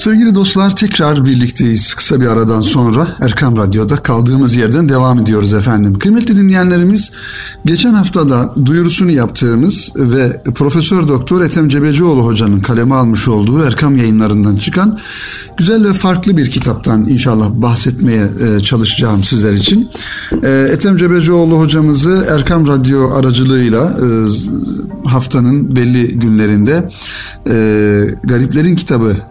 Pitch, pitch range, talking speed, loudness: 130 Hz, 115-170 Hz, 110 wpm, -10 LUFS